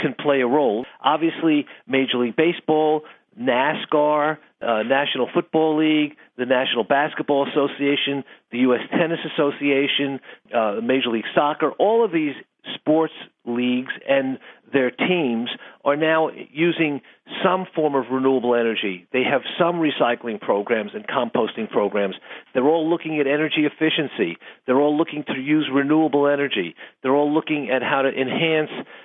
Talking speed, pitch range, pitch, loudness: 145 wpm, 130-160 Hz, 145 Hz, -21 LUFS